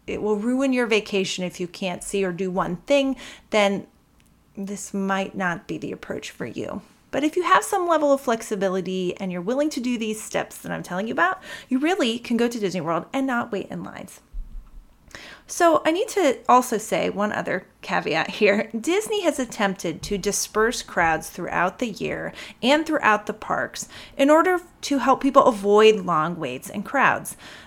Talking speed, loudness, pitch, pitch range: 190 wpm, -23 LUFS, 215 Hz, 195-270 Hz